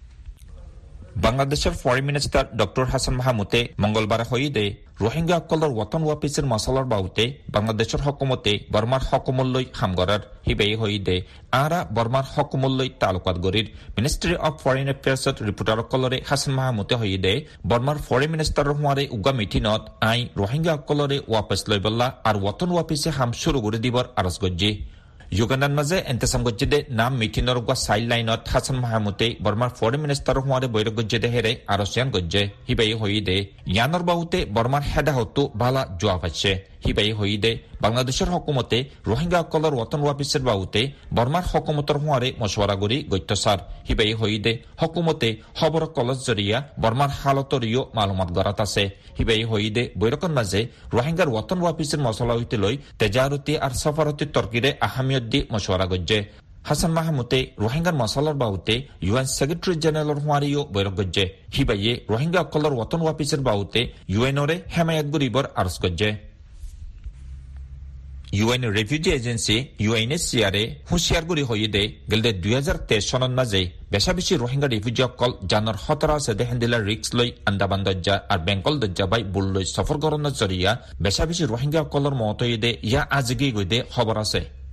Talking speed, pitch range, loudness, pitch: 125 wpm, 105-140 Hz, -23 LUFS, 120 Hz